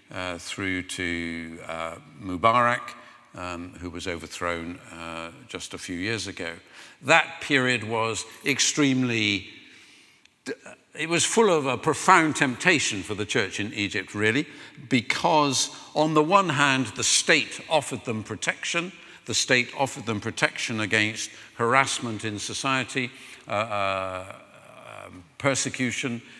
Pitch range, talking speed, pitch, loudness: 95-135 Hz, 125 wpm, 115 Hz, -24 LUFS